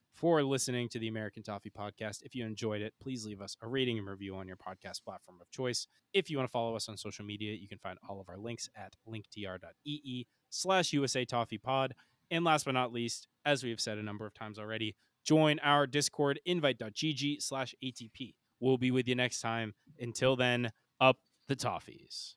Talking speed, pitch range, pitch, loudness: 205 wpm, 110-135 Hz, 120 Hz, -34 LUFS